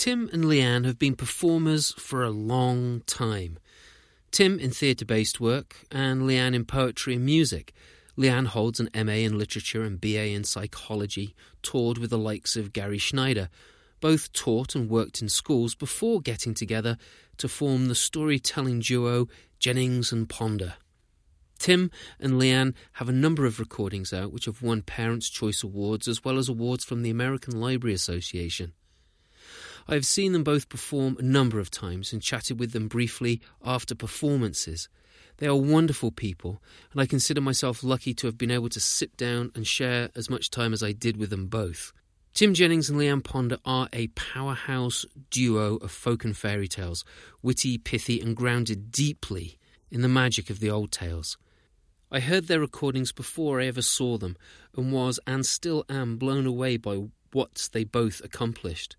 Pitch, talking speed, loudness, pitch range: 120 Hz, 175 wpm, -27 LUFS, 110-130 Hz